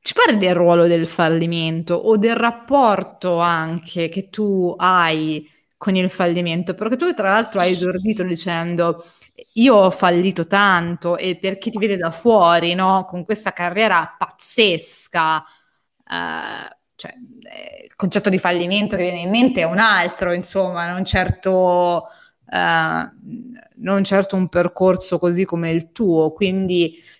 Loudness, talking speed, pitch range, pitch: -17 LUFS, 145 wpm, 170-205 Hz, 185 Hz